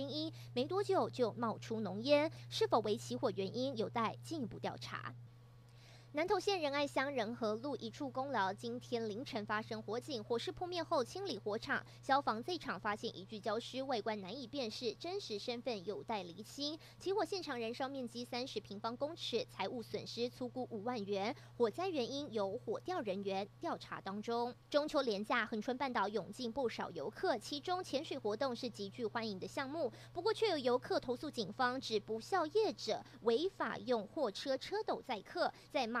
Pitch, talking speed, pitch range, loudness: 245 Hz, 280 characters per minute, 215-290 Hz, -40 LUFS